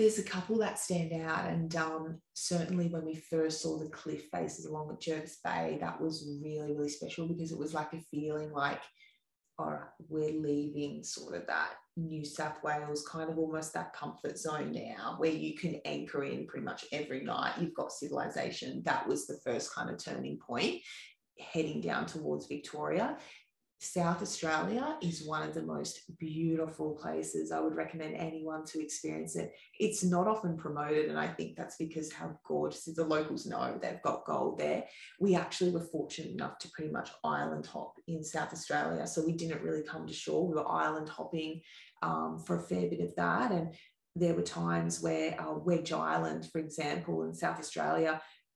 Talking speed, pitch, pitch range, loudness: 190 wpm, 155 Hz, 145-165 Hz, -36 LUFS